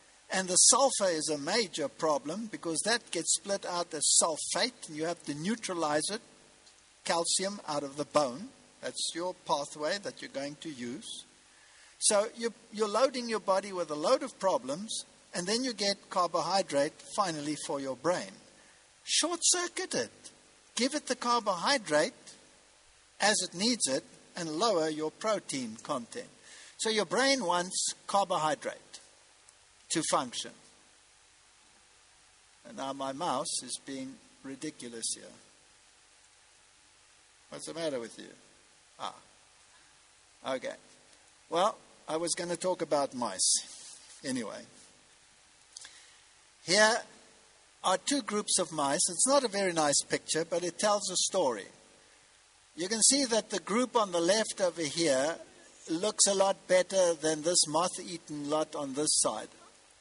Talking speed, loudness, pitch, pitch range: 140 wpm, -30 LUFS, 185 Hz, 155-225 Hz